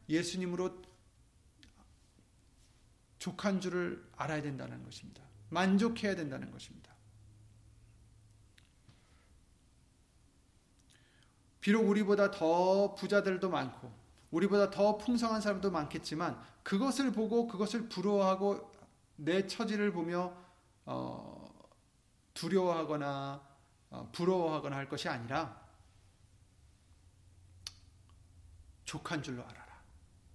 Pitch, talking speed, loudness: 140 Hz, 200 characters per minute, -34 LUFS